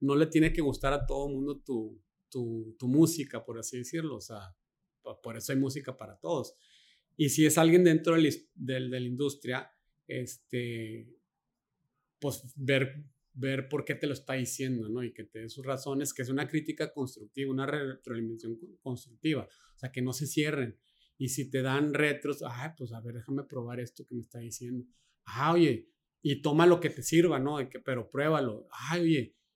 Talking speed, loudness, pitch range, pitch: 190 wpm, -31 LUFS, 125-150 Hz, 135 Hz